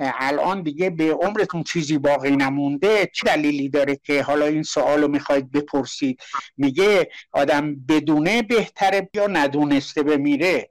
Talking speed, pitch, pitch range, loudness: 130 wpm, 150 Hz, 145-195 Hz, -20 LUFS